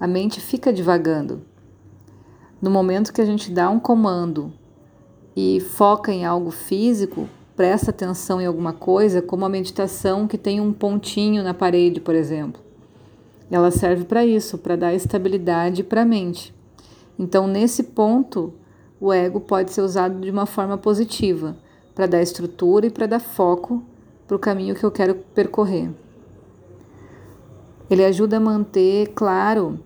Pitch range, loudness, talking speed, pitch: 170-205 Hz, -20 LUFS, 150 wpm, 190 Hz